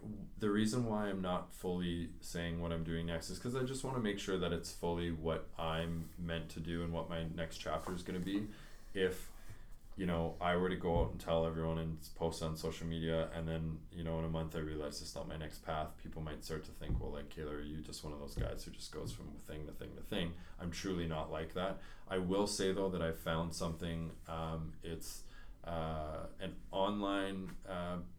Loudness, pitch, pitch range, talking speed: -41 LUFS, 85 Hz, 80-90 Hz, 230 wpm